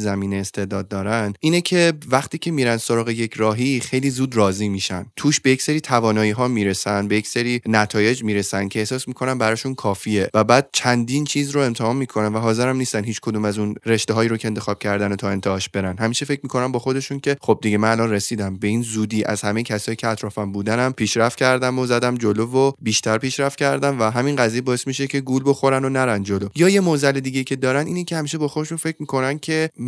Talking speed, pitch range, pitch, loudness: 215 wpm, 105-135 Hz, 120 Hz, -20 LUFS